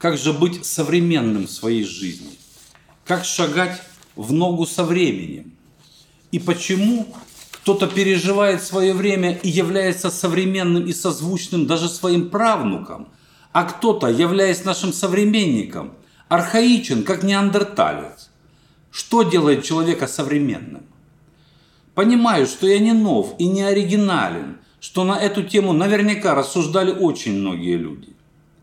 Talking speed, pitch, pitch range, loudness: 115 wpm, 180 Hz, 160-195 Hz, -19 LUFS